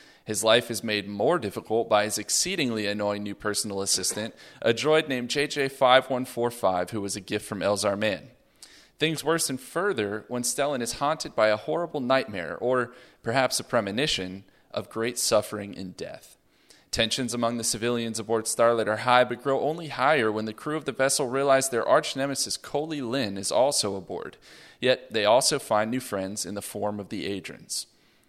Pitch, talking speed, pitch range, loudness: 115 Hz, 175 wpm, 105-130 Hz, -26 LUFS